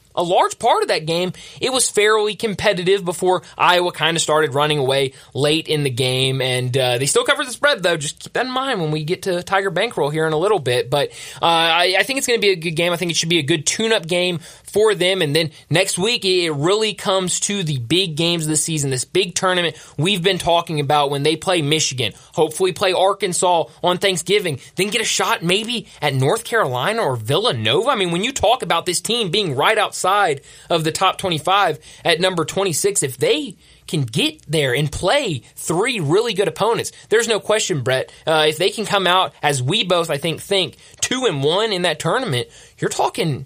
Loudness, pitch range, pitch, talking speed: -18 LUFS, 155-195 Hz, 175 Hz, 225 wpm